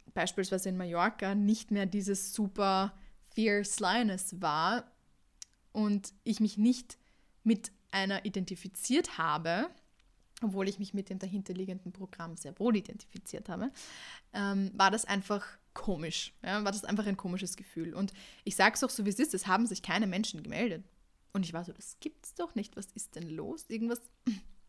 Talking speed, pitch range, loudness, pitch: 170 wpm, 190-220 Hz, -34 LUFS, 200 Hz